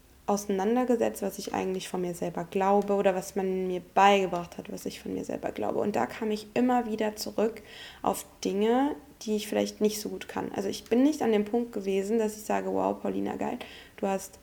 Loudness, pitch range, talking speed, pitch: -29 LUFS, 190-220 Hz, 215 wpm, 205 Hz